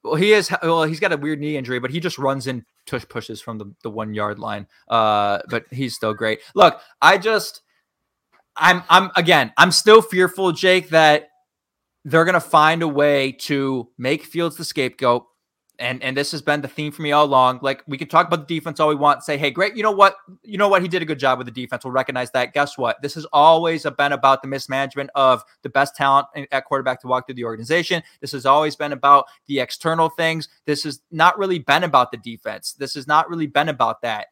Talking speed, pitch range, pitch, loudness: 235 wpm, 130-165 Hz, 145 Hz, -18 LUFS